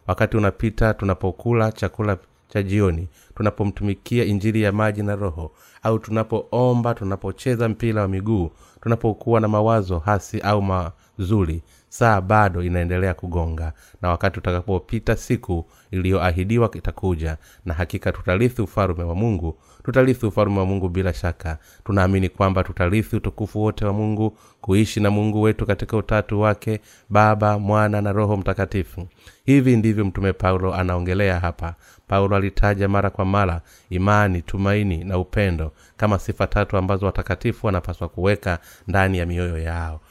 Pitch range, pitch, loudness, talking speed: 90-110 Hz, 100 Hz, -21 LUFS, 135 wpm